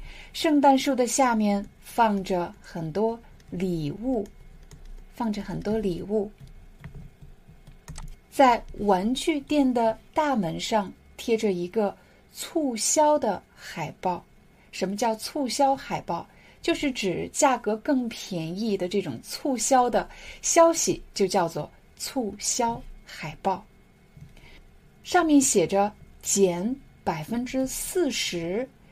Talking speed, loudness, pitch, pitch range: 155 characters per minute, -25 LUFS, 225 Hz, 195-270 Hz